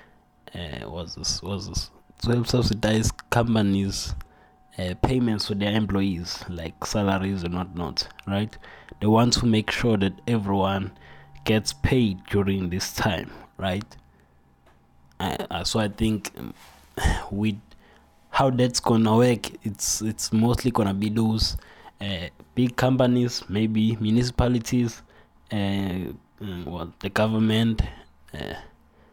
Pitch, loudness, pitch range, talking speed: 100 Hz, -25 LUFS, 90-115 Hz, 120 wpm